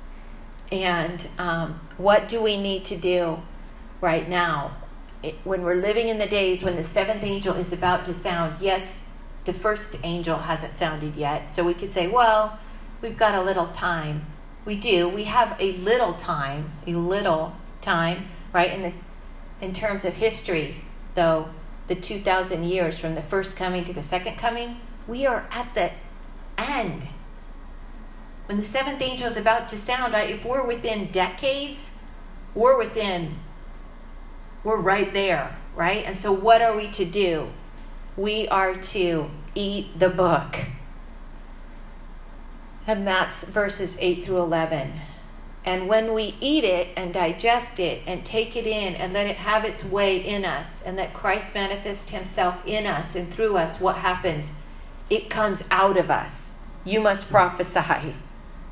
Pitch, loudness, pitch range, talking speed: 190 Hz, -24 LUFS, 175-215 Hz, 155 wpm